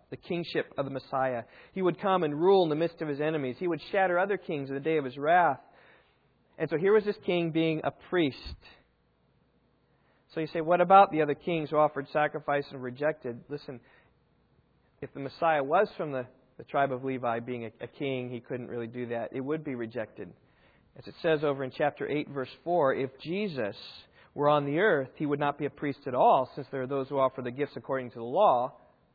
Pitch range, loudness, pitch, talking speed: 130-160 Hz, -29 LUFS, 145 Hz, 220 wpm